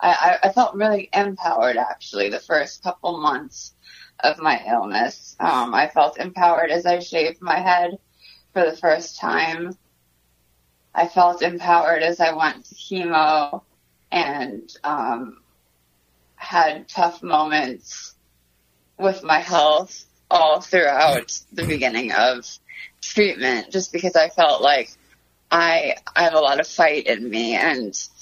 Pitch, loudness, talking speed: 165 Hz, -20 LUFS, 135 wpm